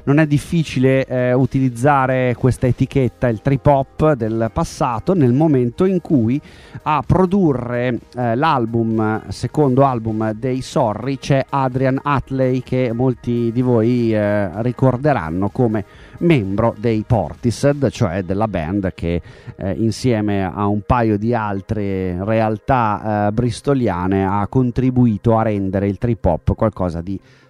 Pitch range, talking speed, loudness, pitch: 105-130 Hz, 130 wpm, -18 LUFS, 120 Hz